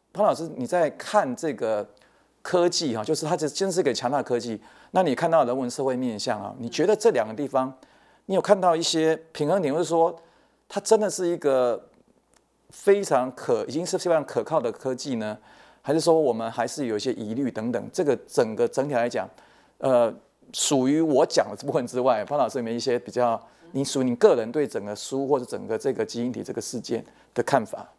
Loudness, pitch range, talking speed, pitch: -25 LUFS, 120-170 Hz, 305 characters per minute, 140 Hz